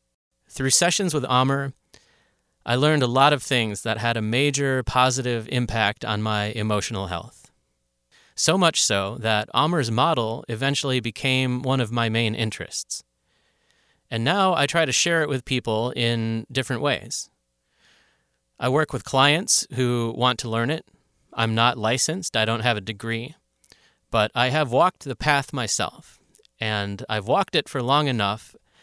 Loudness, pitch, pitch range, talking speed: -22 LUFS, 120 Hz, 110-135 Hz, 160 wpm